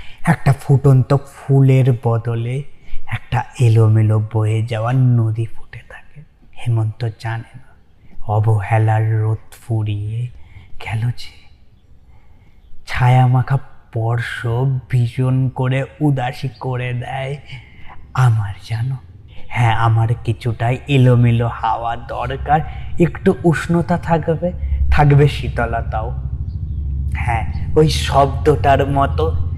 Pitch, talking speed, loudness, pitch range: 115 Hz, 90 wpm, -17 LUFS, 105-130 Hz